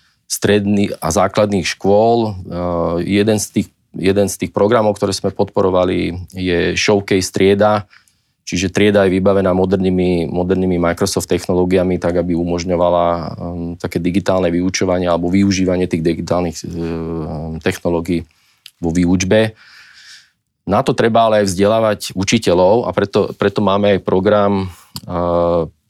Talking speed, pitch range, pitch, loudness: 125 wpm, 85-100 Hz, 95 Hz, -16 LUFS